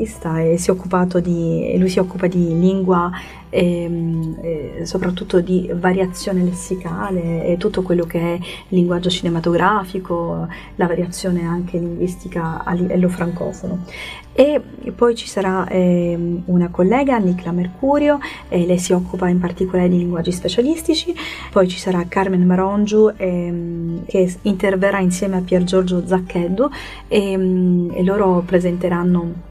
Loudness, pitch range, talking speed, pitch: -18 LUFS, 175-190 Hz, 130 wpm, 180 Hz